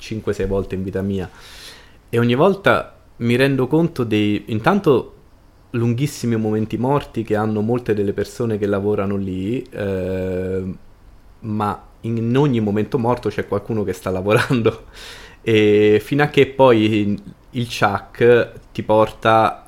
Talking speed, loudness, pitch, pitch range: 135 wpm, -19 LUFS, 110 Hz, 100-120 Hz